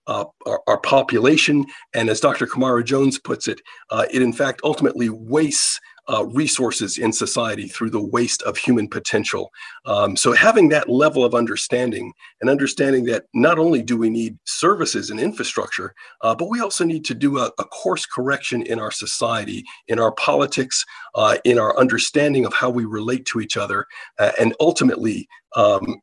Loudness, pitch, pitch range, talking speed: -19 LUFS, 130 Hz, 115-140 Hz, 175 wpm